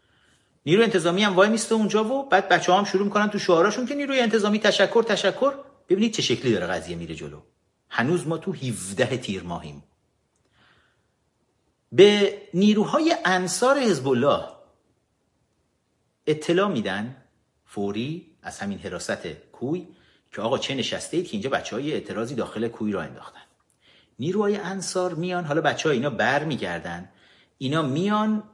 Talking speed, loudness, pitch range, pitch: 145 wpm, -23 LUFS, 130-210 Hz, 185 Hz